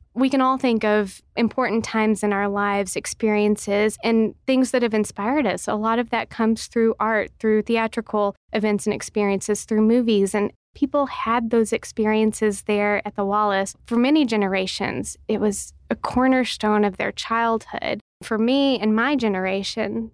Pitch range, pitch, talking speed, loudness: 210-230 Hz, 220 Hz, 165 wpm, -22 LUFS